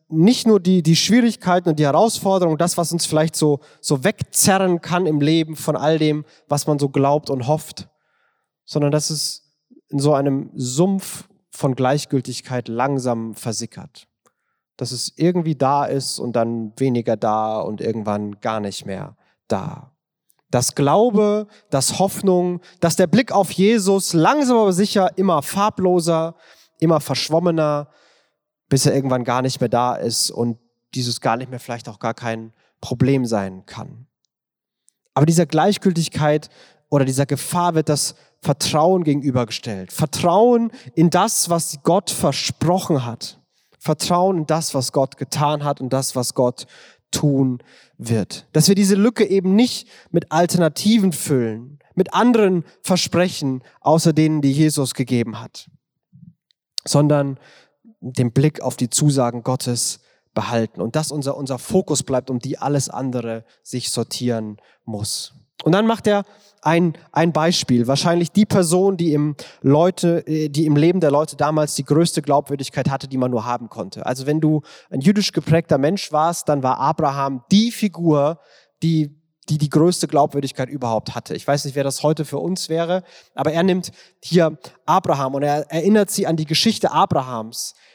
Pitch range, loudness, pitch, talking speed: 130-175 Hz, -19 LUFS, 150 Hz, 155 wpm